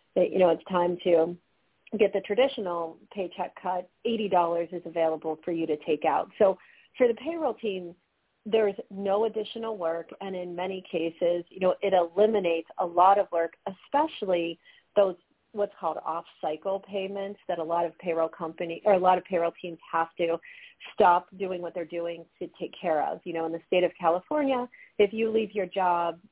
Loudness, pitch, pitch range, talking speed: -28 LUFS, 180 Hz, 170-205 Hz, 185 wpm